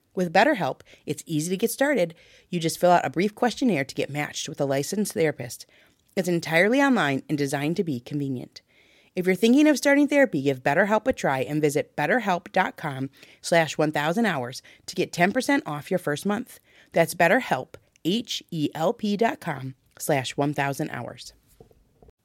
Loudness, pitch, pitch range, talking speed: -24 LUFS, 165 Hz, 145-210 Hz, 155 wpm